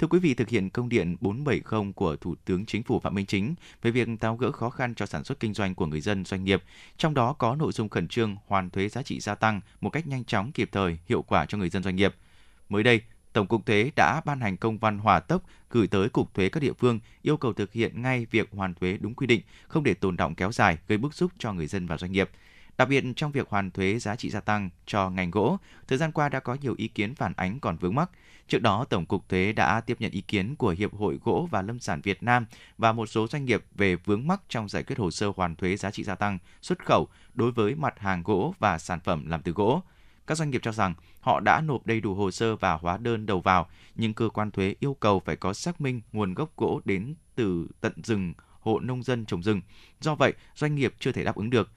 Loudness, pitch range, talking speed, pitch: -27 LUFS, 95-120 Hz, 265 wpm, 105 Hz